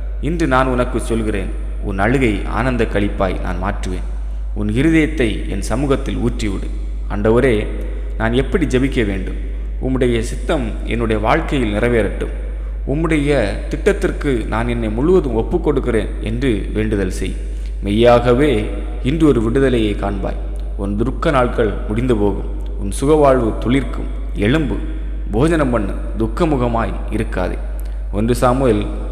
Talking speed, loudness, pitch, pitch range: 110 wpm, -18 LUFS, 110 Hz, 100-130 Hz